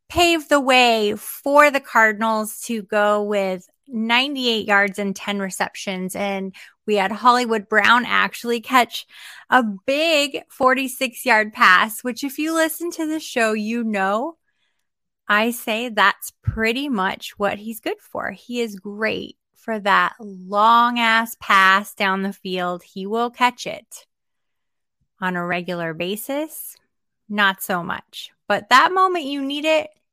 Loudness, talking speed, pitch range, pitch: -19 LUFS, 145 wpm, 200-260 Hz, 225 Hz